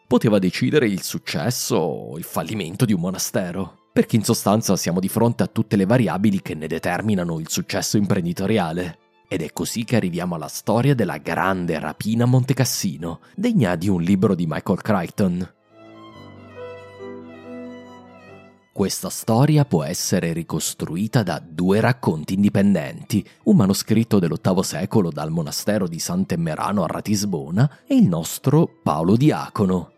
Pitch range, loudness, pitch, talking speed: 85-120 Hz, -21 LUFS, 100 Hz, 135 wpm